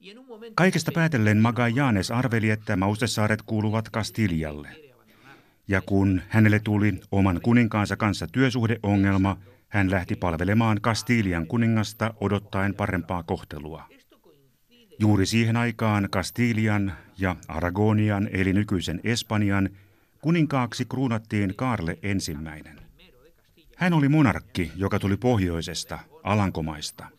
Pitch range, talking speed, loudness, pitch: 95-115 Hz, 100 wpm, -24 LUFS, 105 Hz